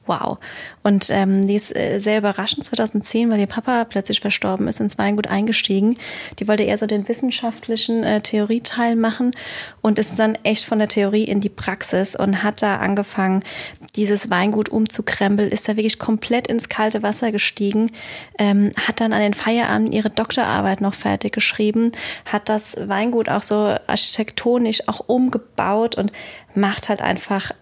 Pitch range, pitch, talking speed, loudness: 205-225 Hz, 215 Hz, 160 wpm, -19 LUFS